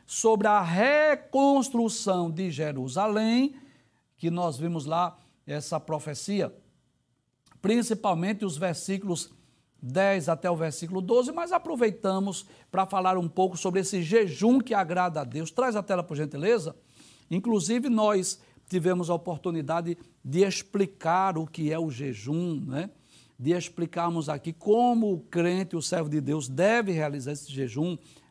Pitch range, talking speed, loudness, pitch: 160-205 Hz, 135 wpm, -27 LUFS, 180 Hz